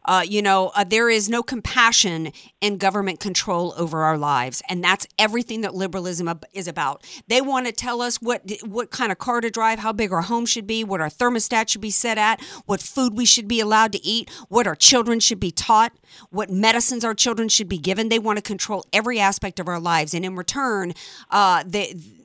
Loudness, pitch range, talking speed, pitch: -20 LUFS, 190-235 Hz, 220 wpm, 215 Hz